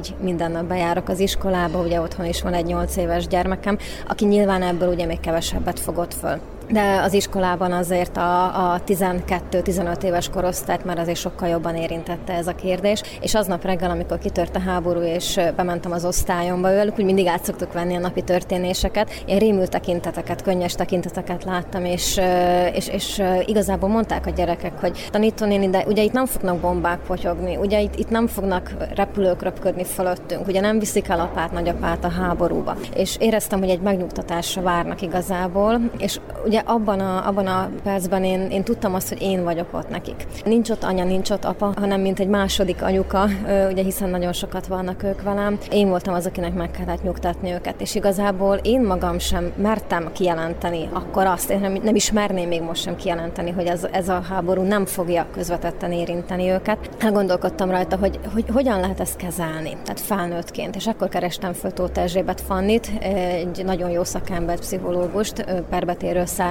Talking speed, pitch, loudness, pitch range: 175 wpm, 185 Hz, -22 LUFS, 175-195 Hz